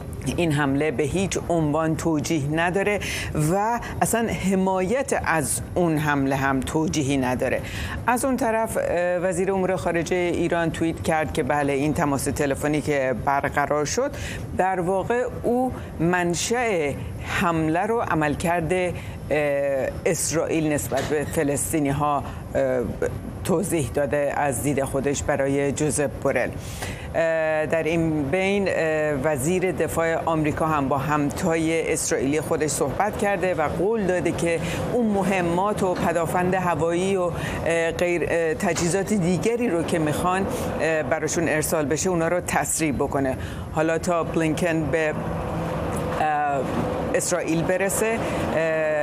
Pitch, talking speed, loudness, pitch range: 165 Hz, 115 wpm, -23 LUFS, 145-180 Hz